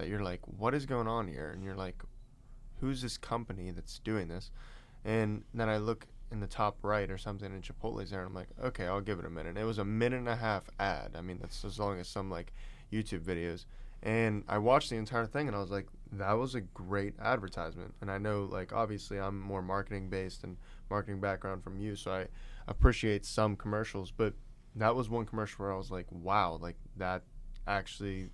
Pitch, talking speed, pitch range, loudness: 105 Hz, 220 wpm, 95-115 Hz, -36 LUFS